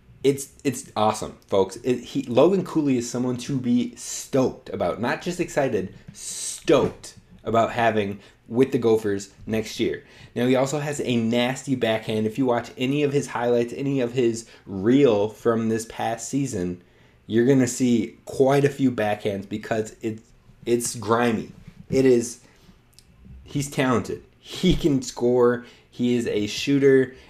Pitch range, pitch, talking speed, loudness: 110-135 Hz, 120 Hz, 150 wpm, -23 LUFS